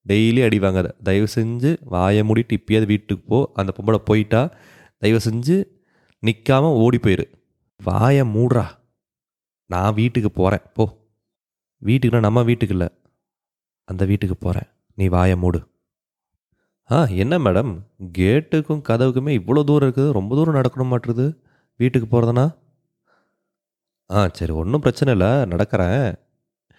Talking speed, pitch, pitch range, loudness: 120 wpm, 115 Hz, 100-130 Hz, -19 LUFS